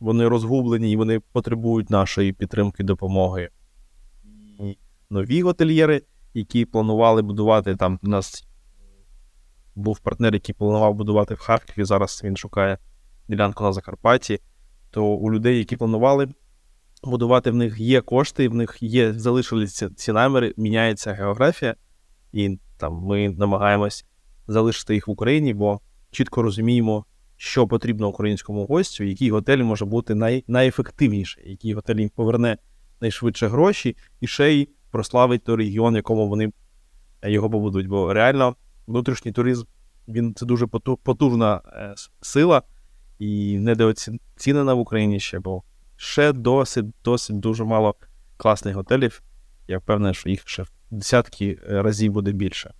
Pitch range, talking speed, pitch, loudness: 100-120 Hz, 135 wpm, 110 Hz, -21 LUFS